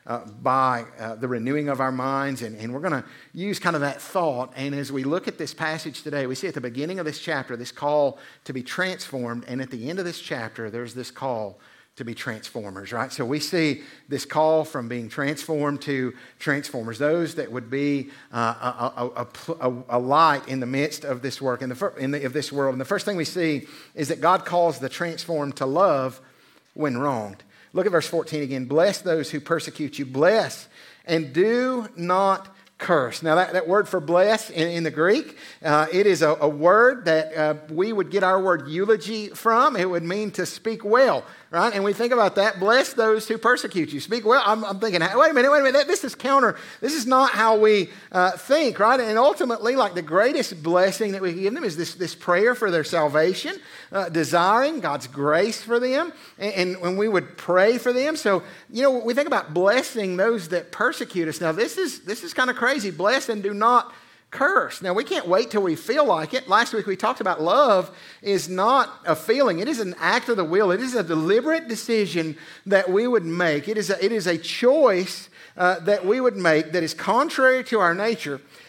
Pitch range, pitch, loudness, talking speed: 140-210 Hz, 170 Hz, -22 LUFS, 220 wpm